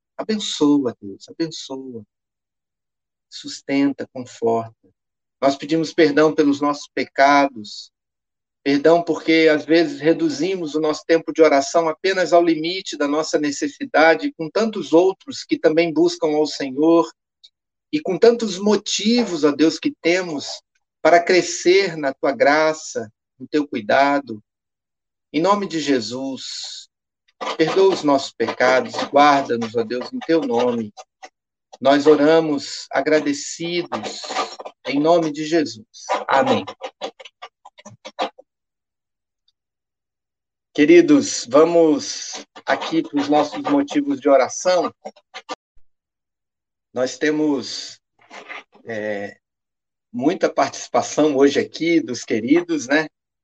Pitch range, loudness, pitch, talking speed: 135-170 Hz, -19 LUFS, 155 Hz, 105 wpm